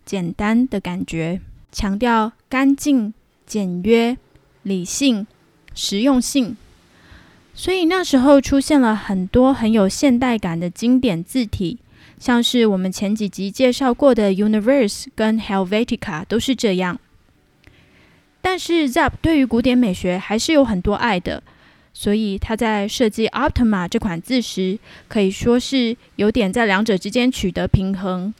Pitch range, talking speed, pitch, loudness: 200-255 Hz, 250 characters per minute, 225 Hz, -18 LUFS